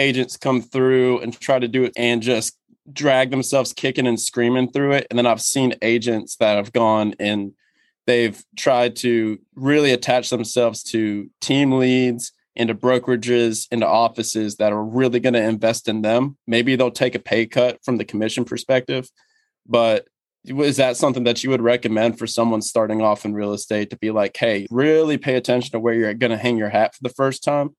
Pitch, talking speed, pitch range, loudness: 120 Hz, 195 wpm, 115-130 Hz, -19 LUFS